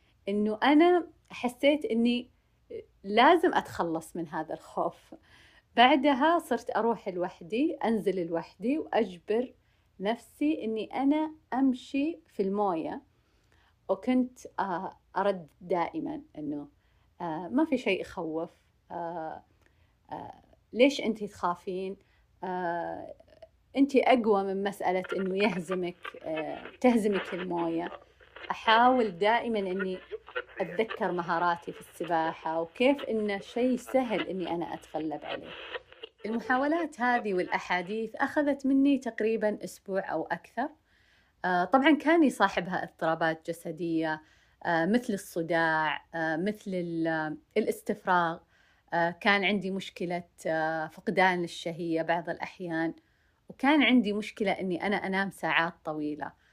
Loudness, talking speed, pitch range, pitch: -29 LUFS, 95 wpm, 170-250 Hz, 200 Hz